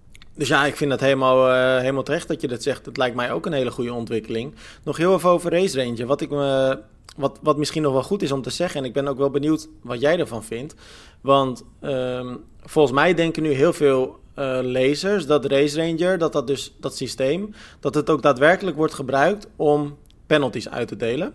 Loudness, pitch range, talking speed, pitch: -21 LUFS, 130-155 Hz, 220 wpm, 140 Hz